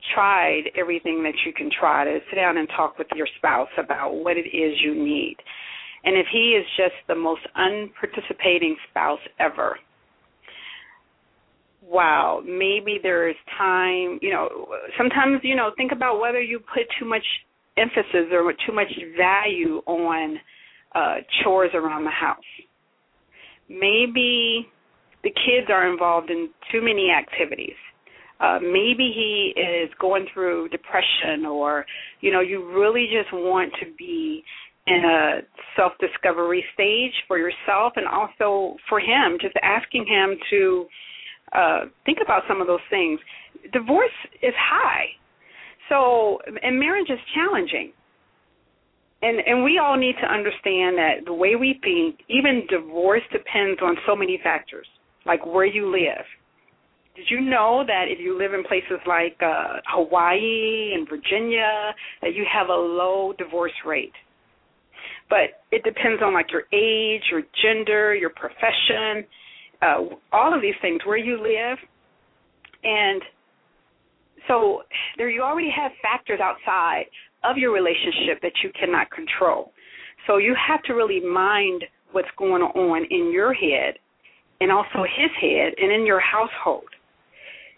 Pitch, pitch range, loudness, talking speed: 210 Hz, 180-260 Hz, -21 LUFS, 145 wpm